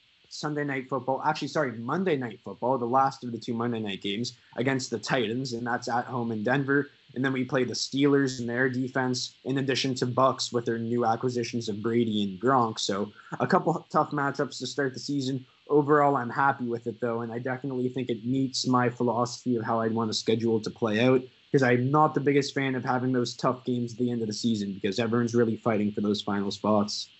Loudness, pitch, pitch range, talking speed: -27 LUFS, 125 Hz, 115-135 Hz, 225 wpm